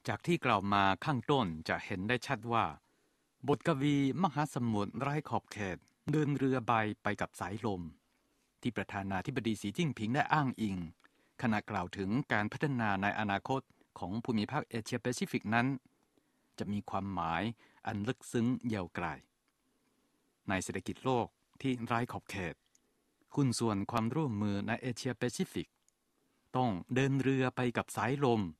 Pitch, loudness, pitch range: 120 Hz, -35 LUFS, 100-135 Hz